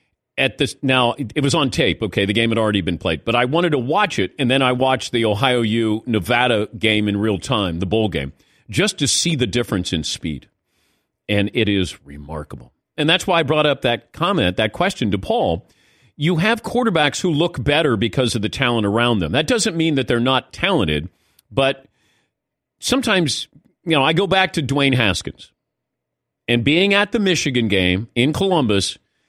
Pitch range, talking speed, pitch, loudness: 105-150 Hz, 195 wpm, 125 Hz, -18 LUFS